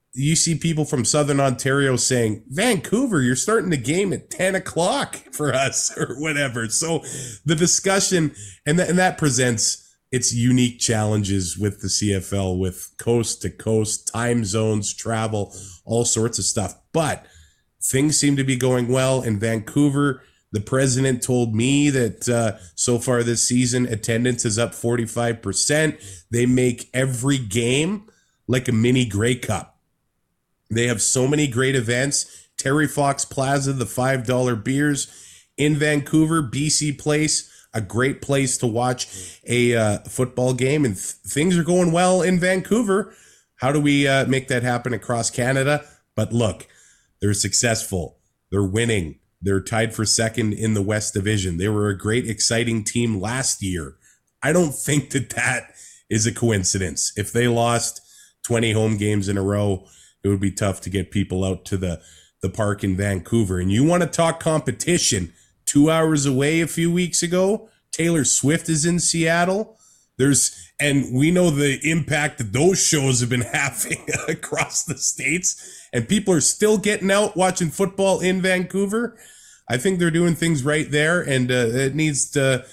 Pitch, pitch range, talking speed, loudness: 125 Hz, 110-150 Hz, 165 wpm, -20 LUFS